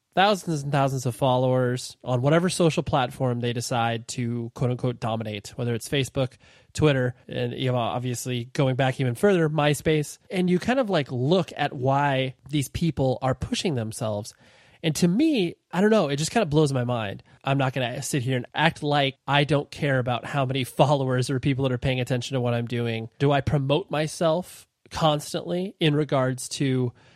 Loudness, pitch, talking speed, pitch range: -25 LUFS, 135 Hz, 195 wpm, 125-150 Hz